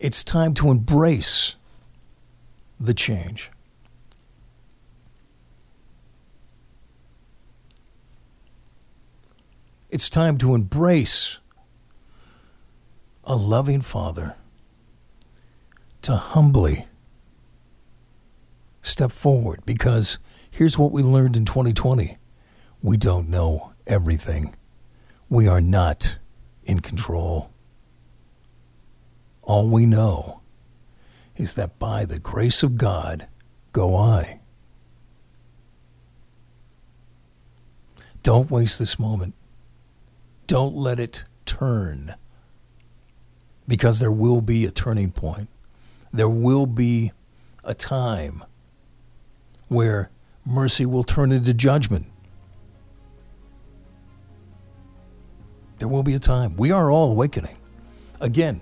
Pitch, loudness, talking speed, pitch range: 105 Hz, -20 LUFS, 85 wpm, 75-120 Hz